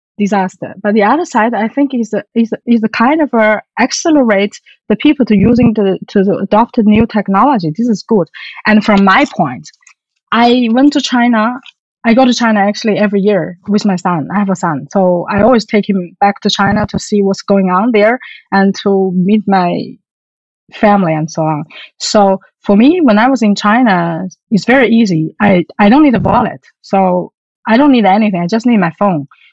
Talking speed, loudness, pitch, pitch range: 200 wpm, -11 LUFS, 210 Hz, 195-235 Hz